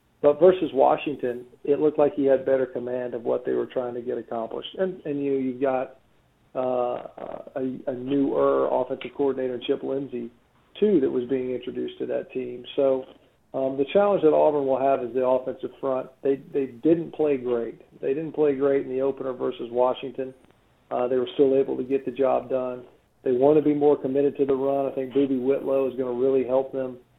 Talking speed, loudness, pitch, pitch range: 205 wpm, -25 LUFS, 135 Hz, 125-140 Hz